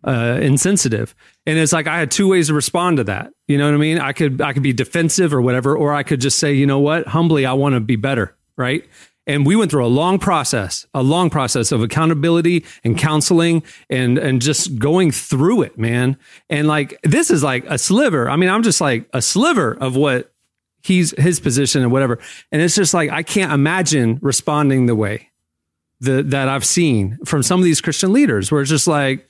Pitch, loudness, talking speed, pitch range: 145 Hz, -16 LUFS, 220 wpm, 130-165 Hz